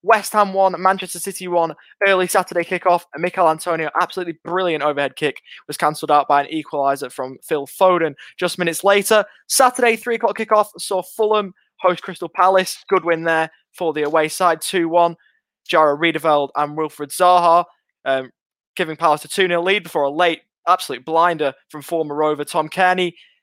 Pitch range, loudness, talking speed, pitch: 155-185 Hz, -18 LUFS, 175 wpm, 175 Hz